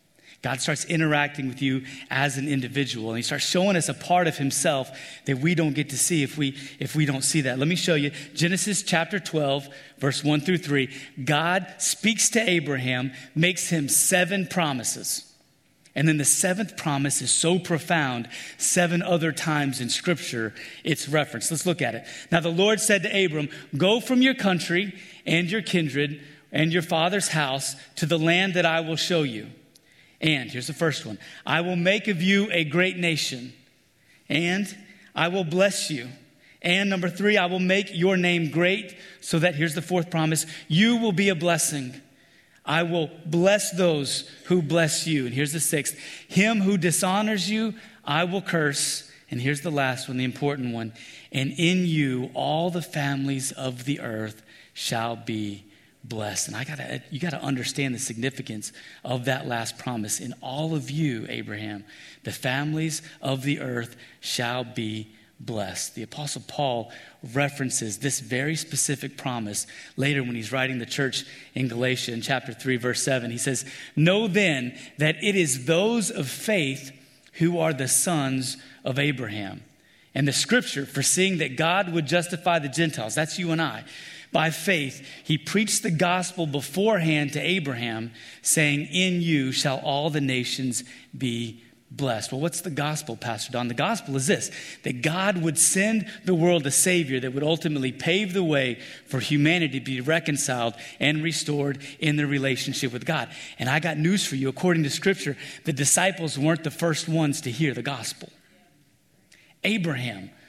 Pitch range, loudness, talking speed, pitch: 135-175 Hz, -24 LUFS, 175 wpm, 150 Hz